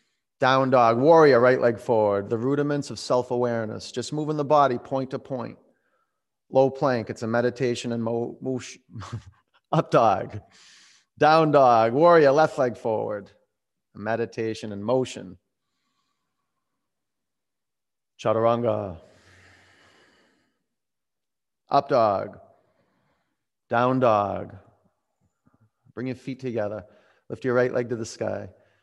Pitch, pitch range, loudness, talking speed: 120 Hz, 110-130 Hz, -23 LUFS, 110 wpm